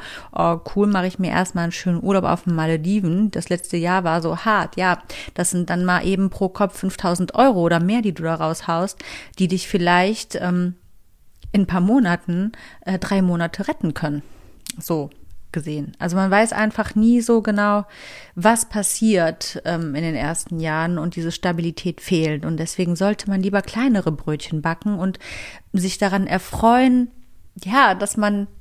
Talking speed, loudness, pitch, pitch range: 170 wpm, -20 LUFS, 185 Hz, 170-205 Hz